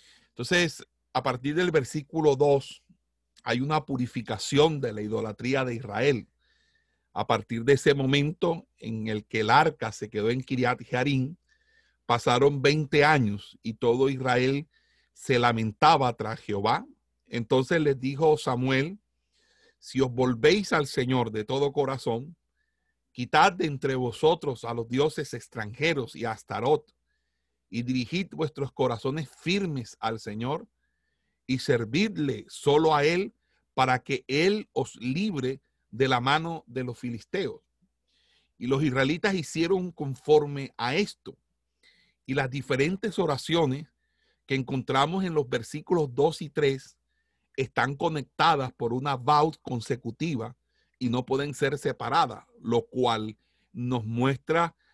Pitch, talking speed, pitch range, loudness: 135 Hz, 130 wpm, 125-155 Hz, -27 LUFS